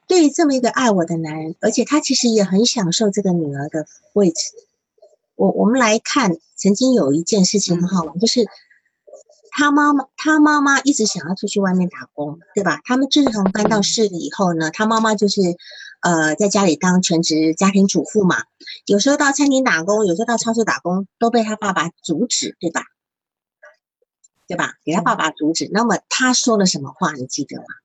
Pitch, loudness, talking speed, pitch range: 205 Hz, -17 LUFS, 285 characters per minute, 175-245 Hz